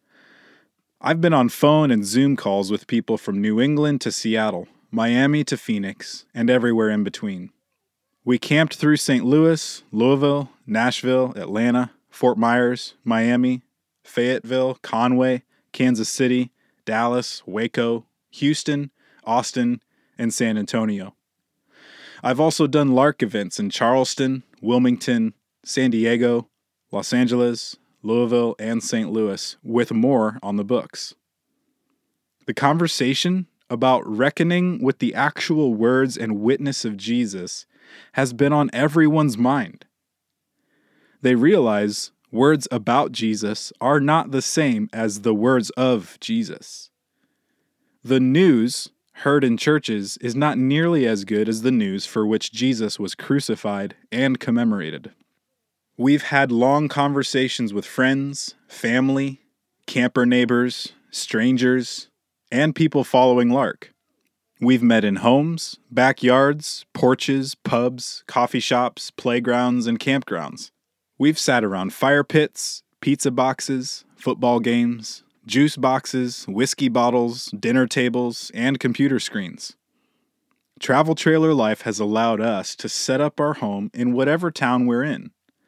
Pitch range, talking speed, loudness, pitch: 115-140 Hz, 125 wpm, -20 LUFS, 125 Hz